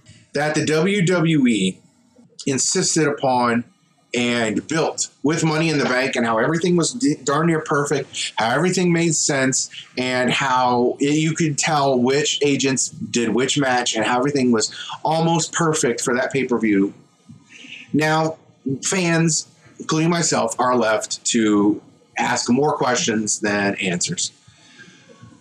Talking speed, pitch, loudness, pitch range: 130 wpm, 140 Hz, -19 LUFS, 120-160 Hz